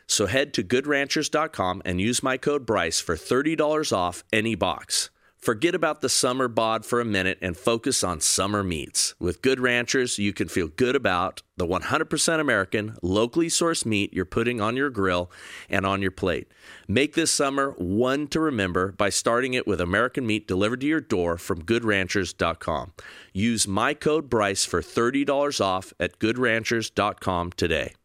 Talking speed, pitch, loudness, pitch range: 165 wpm, 110 Hz, -24 LUFS, 95-135 Hz